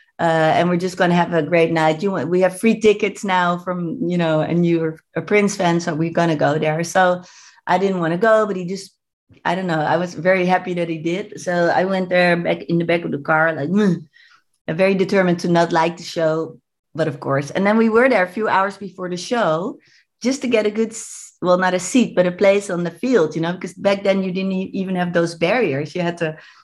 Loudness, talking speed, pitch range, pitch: -19 LUFS, 255 wpm, 165-195 Hz, 180 Hz